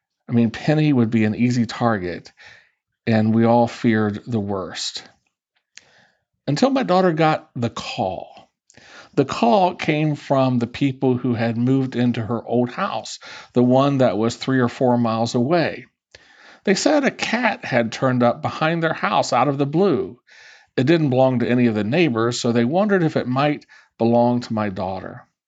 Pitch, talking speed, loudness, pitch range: 125 Hz, 175 wpm, -20 LUFS, 115-145 Hz